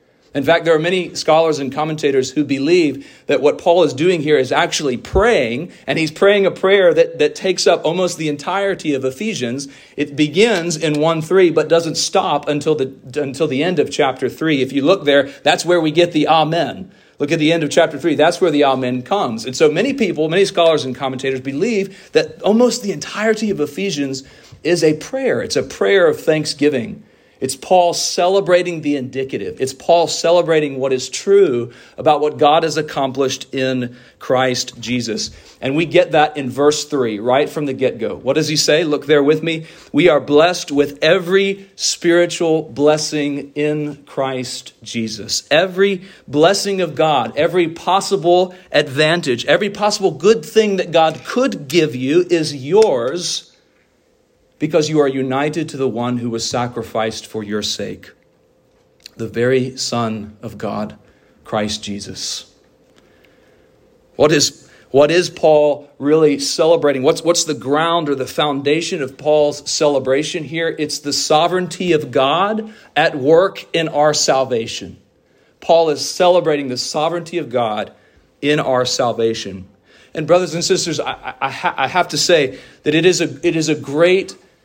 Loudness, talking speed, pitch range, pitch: -16 LUFS, 170 wpm, 135-175 Hz, 155 Hz